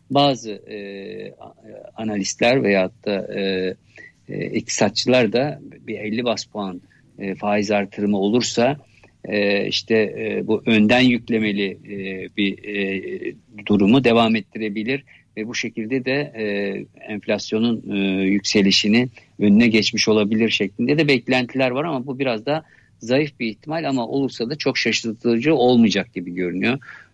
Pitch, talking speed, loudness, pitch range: 110 Hz, 130 wpm, -20 LUFS, 100-120 Hz